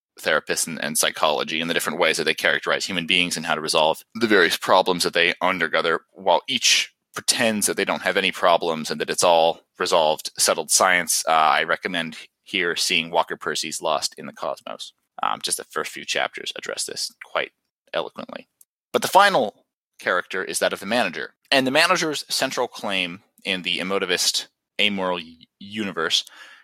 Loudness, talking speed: -21 LUFS, 180 wpm